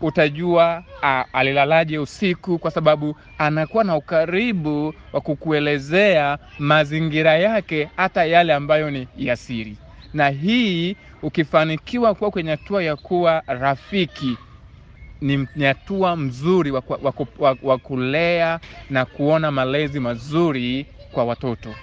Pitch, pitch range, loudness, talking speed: 155 Hz, 135-170 Hz, -20 LUFS, 120 wpm